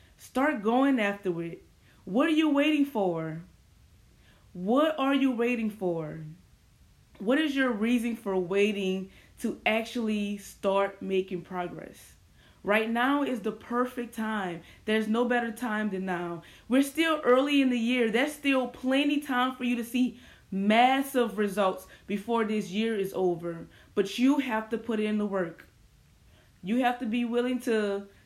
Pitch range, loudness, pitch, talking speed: 195-250 Hz, -28 LUFS, 225 Hz, 155 wpm